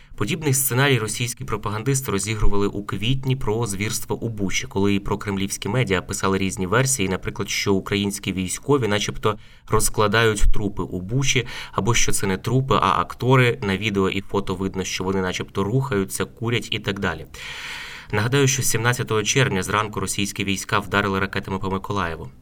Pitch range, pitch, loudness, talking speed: 95-120 Hz, 105 Hz, -22 LUFS, 155 wpm